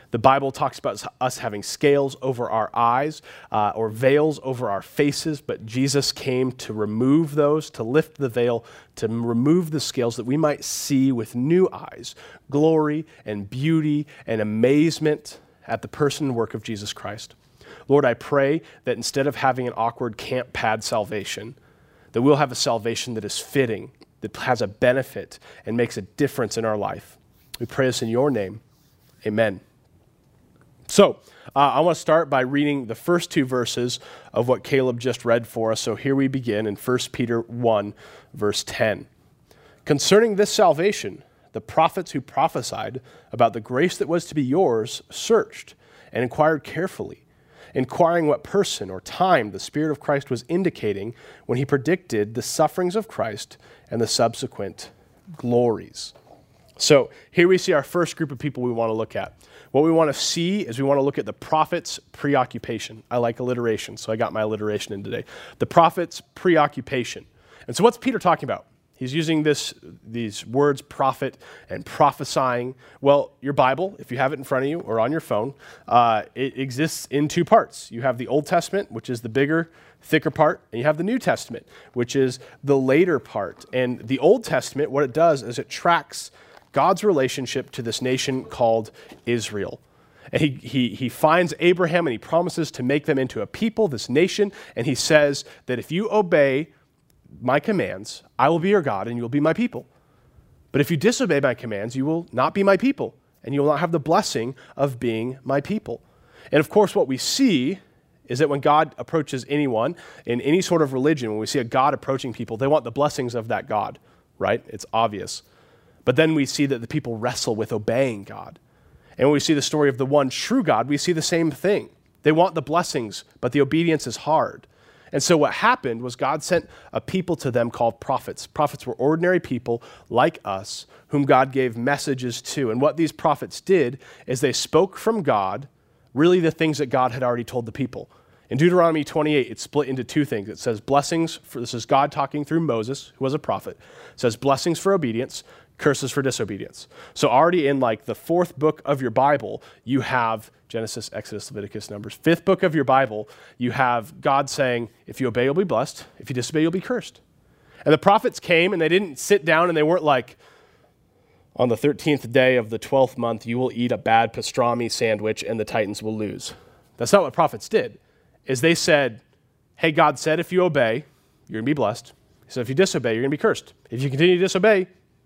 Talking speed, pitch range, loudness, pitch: 200 wpm, 120-155 Hz, -22 LUFS, 135 Hz